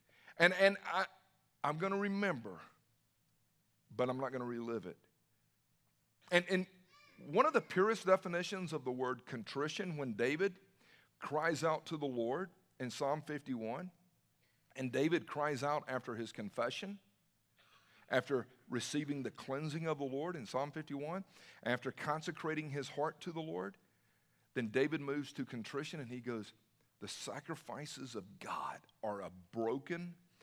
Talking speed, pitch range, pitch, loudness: 145 wpm, 125-175 Hz, 150 Hz, -39 LUFS